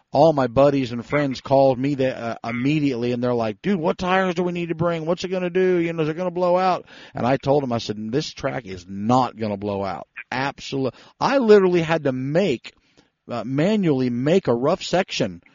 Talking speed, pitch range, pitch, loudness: 230 wpm, 125-180 Hz, 140 Hz, -21 LUFS